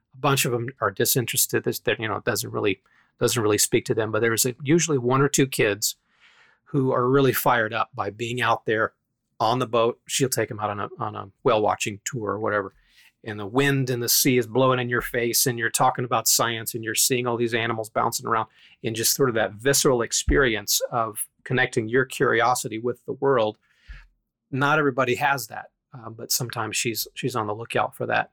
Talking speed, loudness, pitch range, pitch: 215 wpm, -23 LUFS, 115-135 Hz, 125 Hz